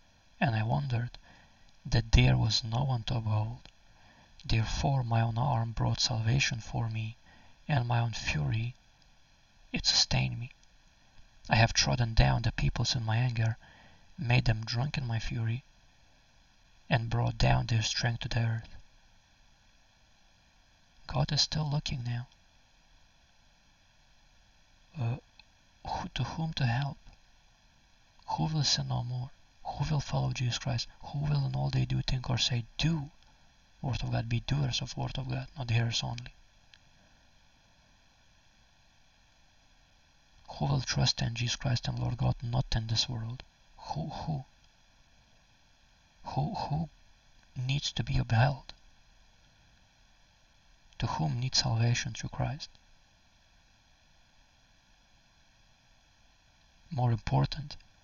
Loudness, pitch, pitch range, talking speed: -31 LUFS, 120 Hz, 115-135 Hz, 125 wpm